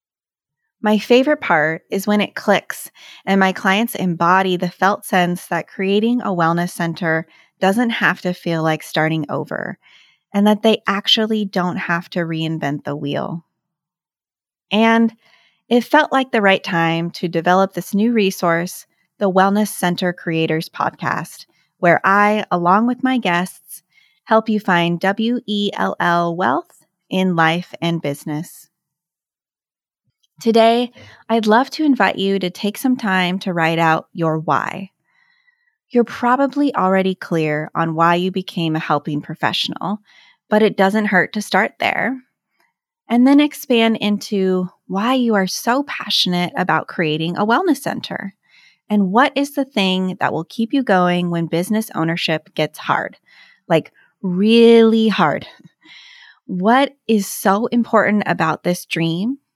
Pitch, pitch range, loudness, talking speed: 190 Hz, 170-225 Hz, -17 LUFS, 140 wpm